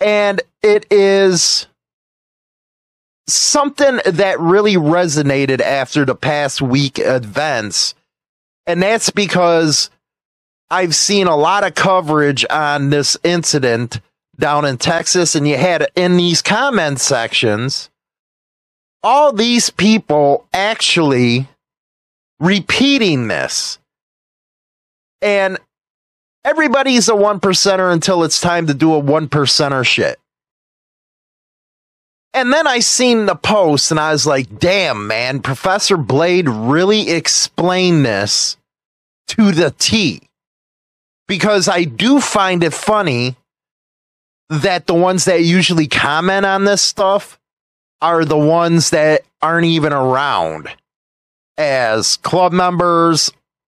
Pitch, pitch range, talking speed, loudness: 170 Hz, 145-195 Hz, 110 wpm, -13 LUFS